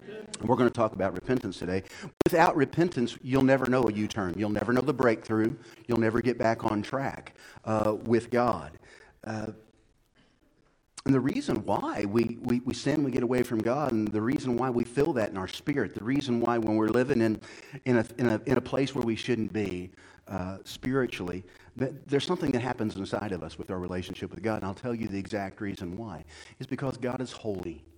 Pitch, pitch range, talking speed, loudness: 115 Hz, 105-125 Hz, 210 wpm, -29 LUFS